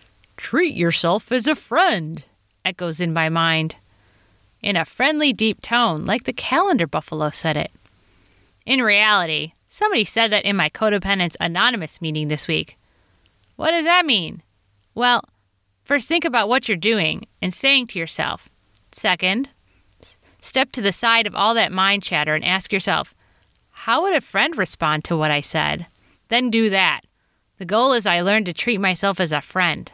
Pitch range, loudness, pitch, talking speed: 155-230 Hz, -19 LUFS, 190 Hz, 165 wpm